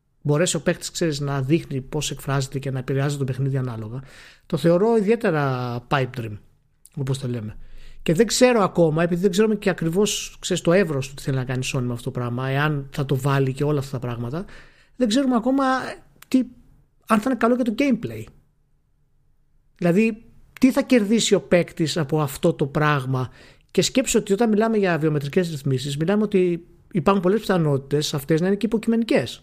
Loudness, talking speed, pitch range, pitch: -22 LUFS, 185 wpm, 135-200 Hz, 155 Hz